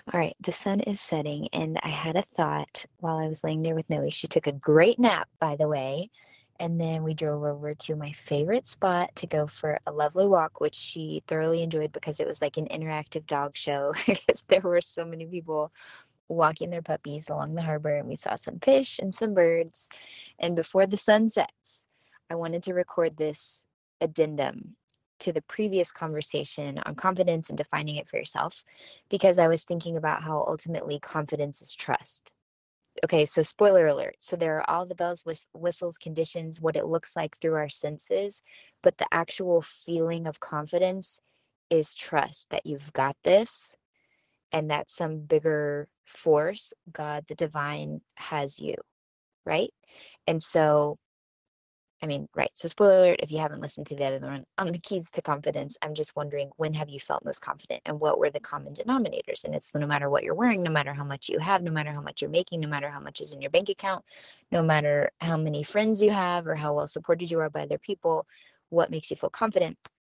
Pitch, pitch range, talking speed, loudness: 160 Hz, 150-175 Hz, 200 wpm, -28 LUFS